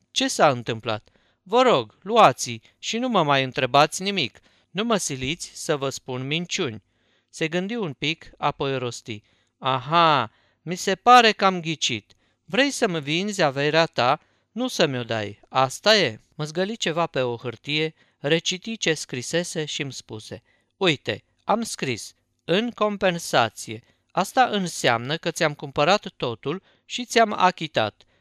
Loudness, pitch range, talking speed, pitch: -23 LUFS, 120-185 Hz, 145 wpm, 155 Hz